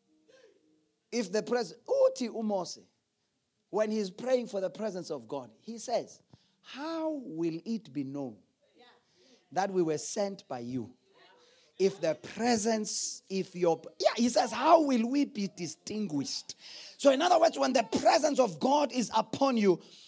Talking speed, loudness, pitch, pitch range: 145 wpm, -30 LUFS, 220 Hz, 180-280 Hz